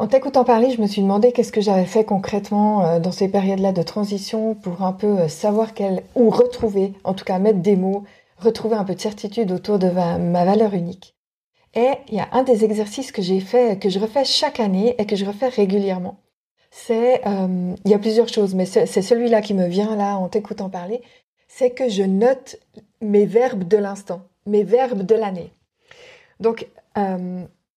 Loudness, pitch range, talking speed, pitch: -19 LUFS, 195-235 Hz, 200 wpm, 210 Hz